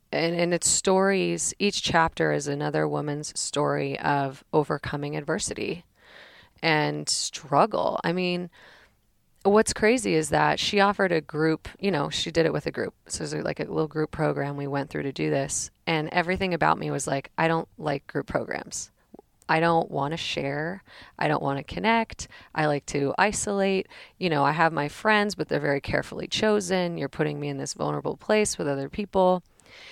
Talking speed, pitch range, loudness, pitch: 185 wpm, 140-185 Hz, -26 LUFS, 160 Hz